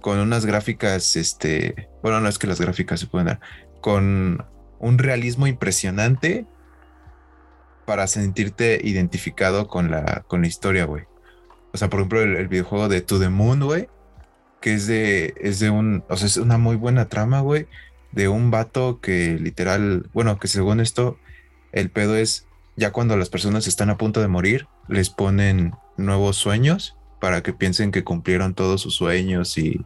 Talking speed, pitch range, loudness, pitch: 175 wpm, 90-110 Hz, -21 LUFS, 100 Hz